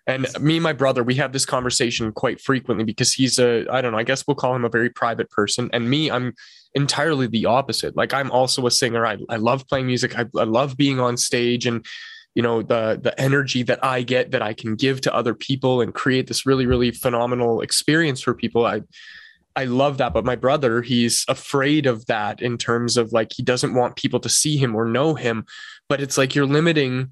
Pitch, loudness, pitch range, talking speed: 125 Hz, -20 LUFS, 120-135 Hz, 230 wpm